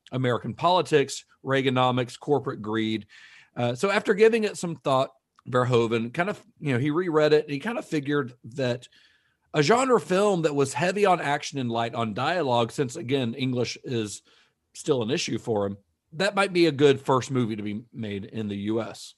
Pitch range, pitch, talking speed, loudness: 115-155 Hz, 135 Hz, 190 wpm, -25 LUFS